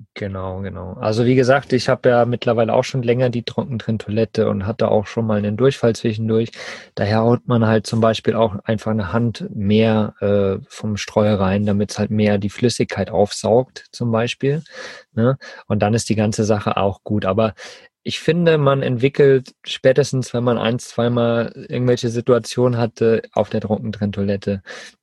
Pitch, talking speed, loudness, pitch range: 115 Hz, 170 wpm, -19 LUFS, 105-125 Hz